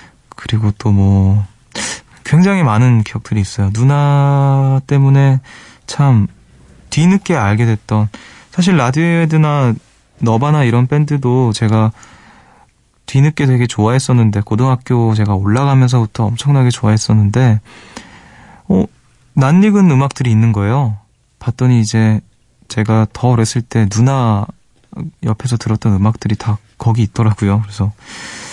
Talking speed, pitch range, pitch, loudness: 275 characters per minute, 110-135 Hz, 115 Hz, -13 LUFS